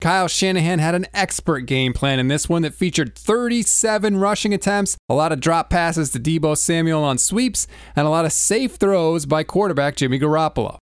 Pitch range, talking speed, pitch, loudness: 150-195 Hz, 195 wpm, 165 Hz, -18 LUFS